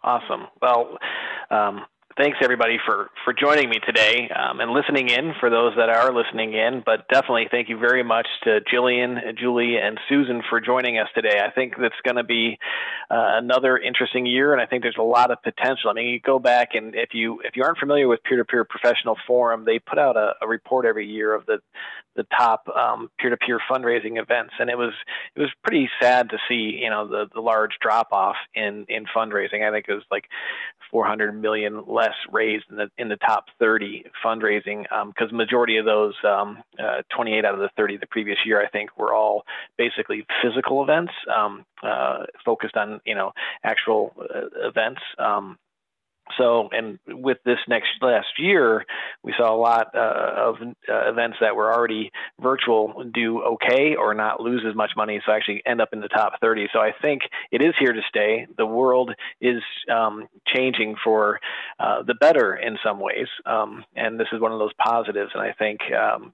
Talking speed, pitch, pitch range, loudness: 205 wpm, 115 Hz, 110-125 Hz, -21 LUFS